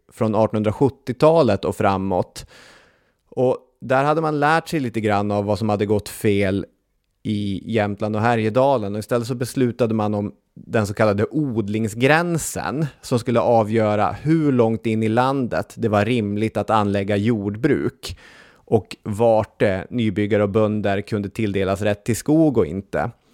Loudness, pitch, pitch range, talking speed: -20 LUFS, 110 Hz, 105-125 Hz, 150 wpm